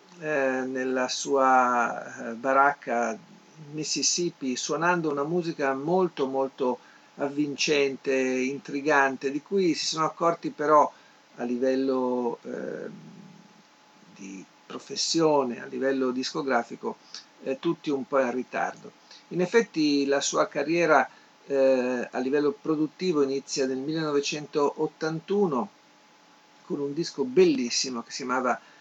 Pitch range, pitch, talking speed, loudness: 130-160 Hz, 145 Hz, 105 wpm, -26 LUFS